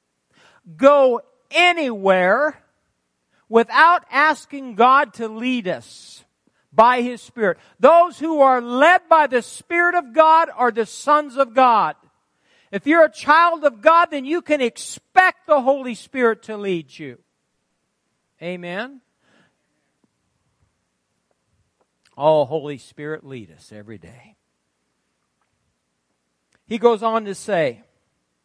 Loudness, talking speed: -17 LUFS, 115 wpm